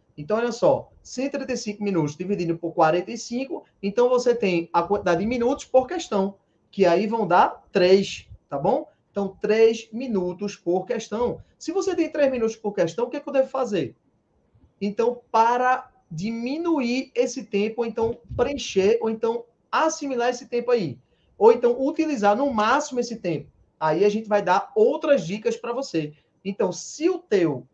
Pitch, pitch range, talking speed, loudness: 230 Hz, 195-260 Hz, 165 wpm, -23 LUFS